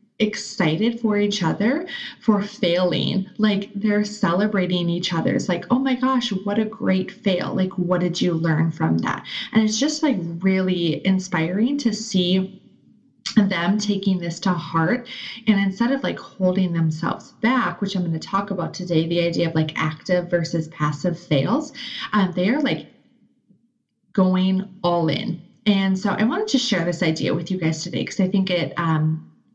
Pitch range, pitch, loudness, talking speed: 175-220 Hz, 190 Hz, -22 LUFS, 175 wpm